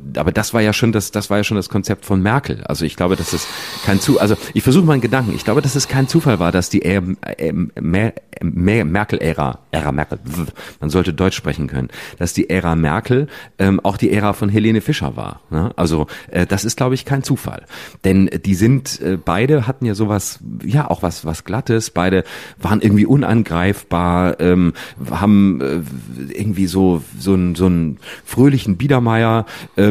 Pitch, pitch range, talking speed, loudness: 100 Hz, 90-115 Hz, 195 wpm, -17 LUFS